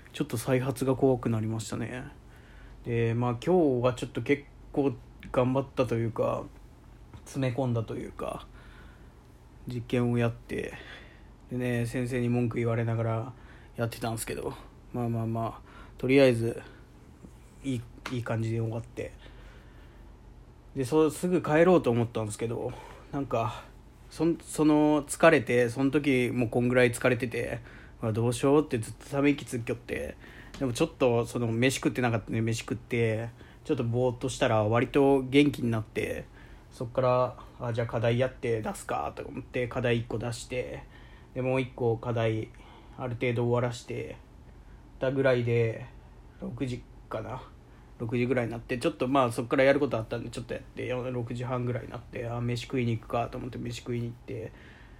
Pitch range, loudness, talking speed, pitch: 115-130 Hz, -29 LUFS, 335 characters per minute, 125 Hz